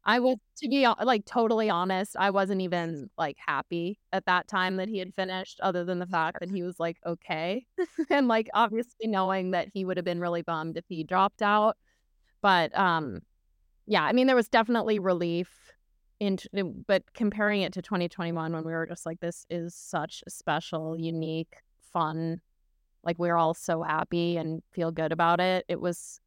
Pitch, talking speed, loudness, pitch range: 180 Hz, 185 wpm, -28 LUFS, 165-205 Hz